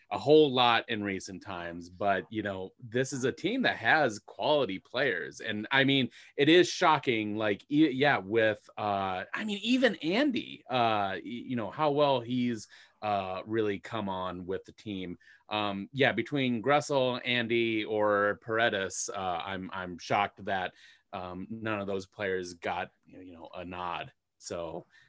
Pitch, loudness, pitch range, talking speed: 110 Hz, -29 LUFS, 95-135 Hz, 165 wpm